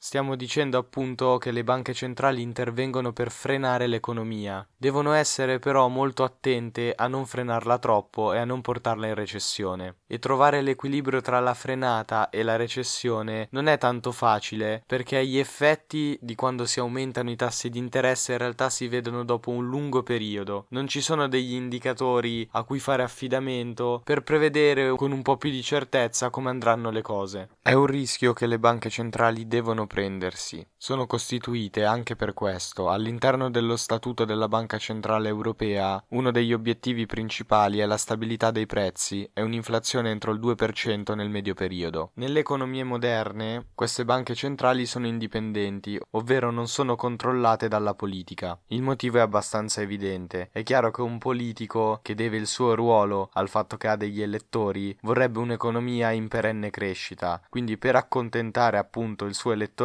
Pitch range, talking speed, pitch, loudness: 110-130 Hz, 165 wpm, 120 Hz, -26 LUFS